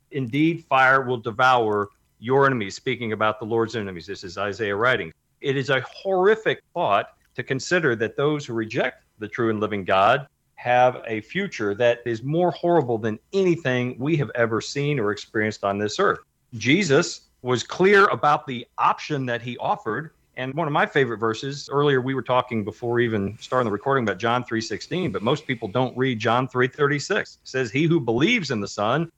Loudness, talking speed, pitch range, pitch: -23 LUFS, 185 wpm, 115-145 Hz, 125 Hz